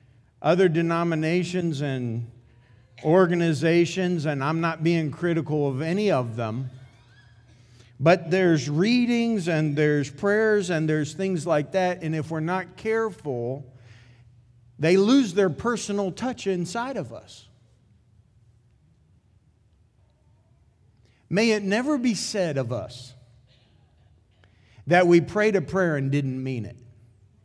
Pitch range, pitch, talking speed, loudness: 120-180 Hz, 150 Hz, 115 wpm, -24 LUFS